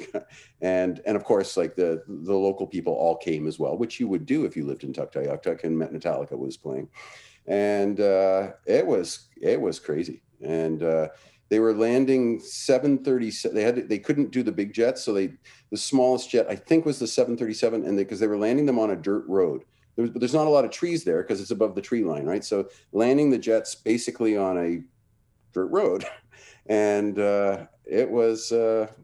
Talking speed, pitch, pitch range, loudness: 210 wpm, 110 Hz, 100-125 Hz, -25 LUFS